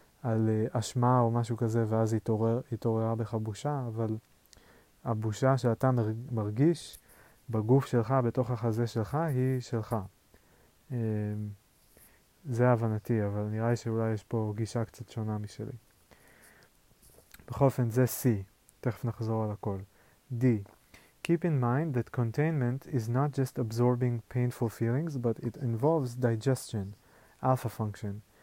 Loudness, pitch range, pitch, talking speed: -31 LUFS, 110-125 Hz, 115 Hz, 130 wpm